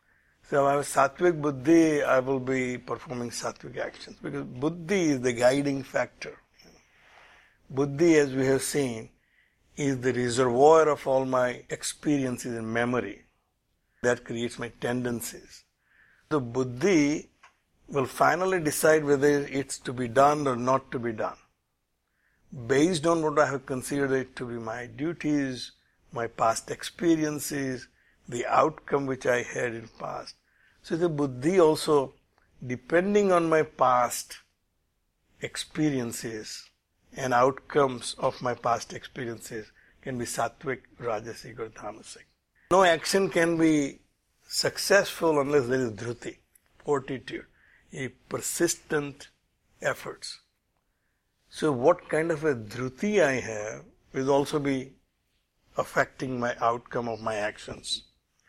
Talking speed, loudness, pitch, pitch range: 125 wpm, -27 LUFS, 135 Hz, 120-150 Hz